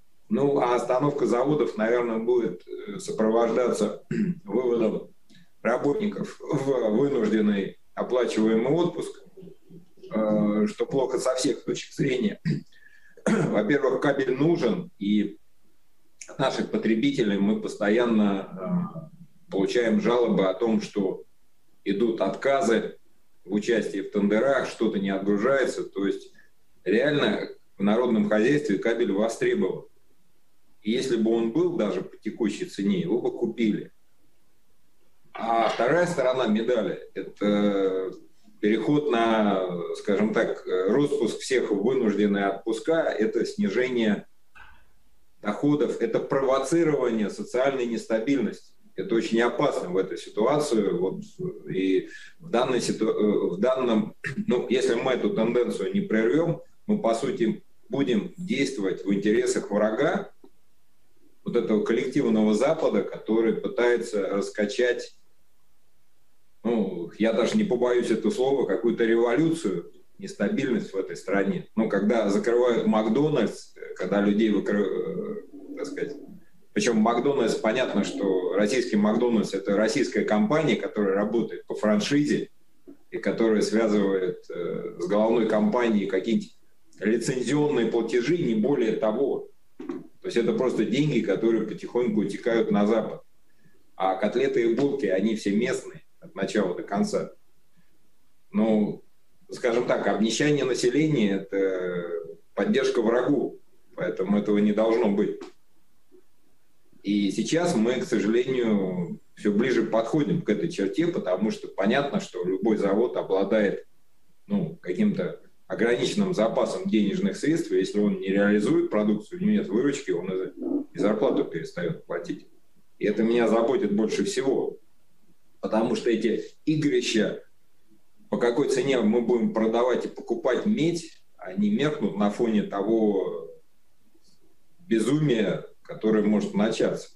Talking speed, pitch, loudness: 115 wpm, 120 Hz, -25 LUFS